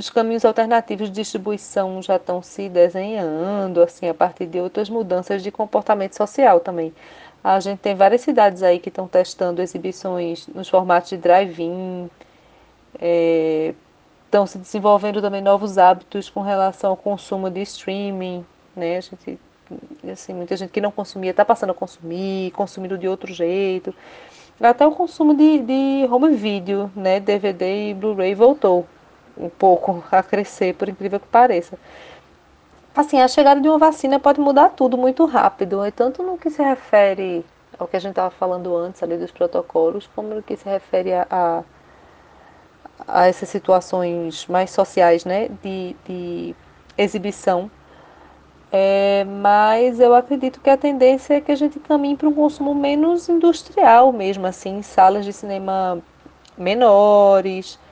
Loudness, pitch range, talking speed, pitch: -18 LUFS, 185-230 Hz, 155 wpm, 195 Hz